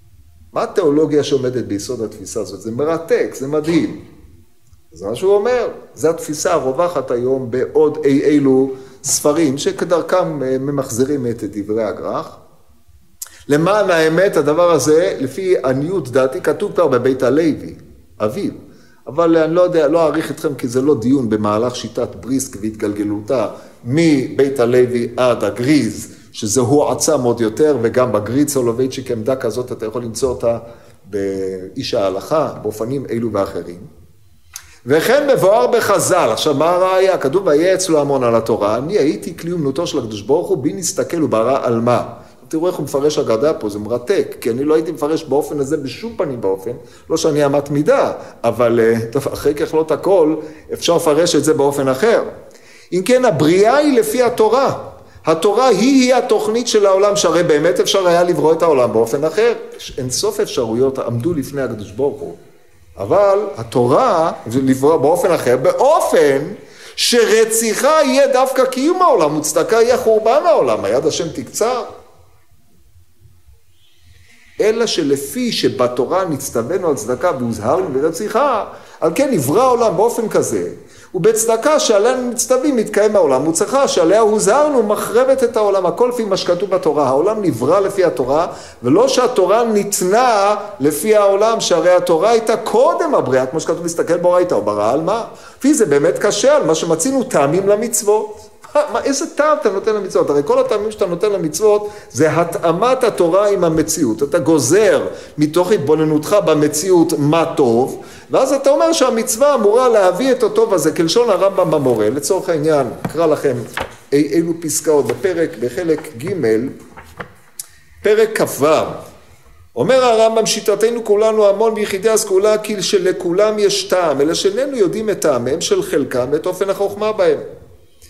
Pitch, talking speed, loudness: 170 Hz, 145 wpm, -15 LUFS